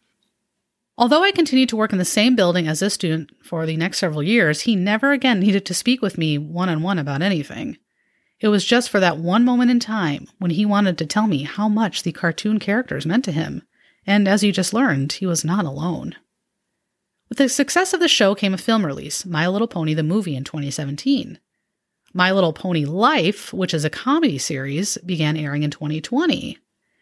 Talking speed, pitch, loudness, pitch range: 205 wpm, 195 Hz, -19 LUFS, 160-225 Hz